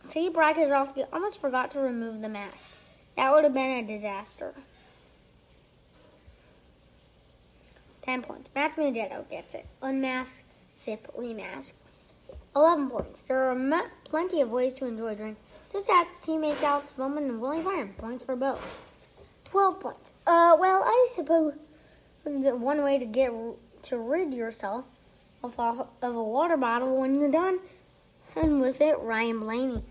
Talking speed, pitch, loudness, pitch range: 150 wpm, 265 Hz, -27 LUFS, 230-305 Hz